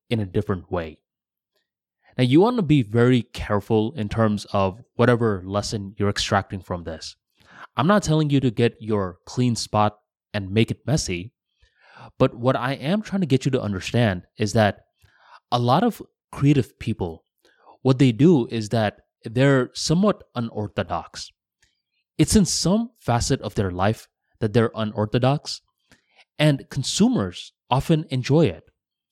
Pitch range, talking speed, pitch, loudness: 105-135 Hz, 150 wpm, 115 Hz, -22 LUFS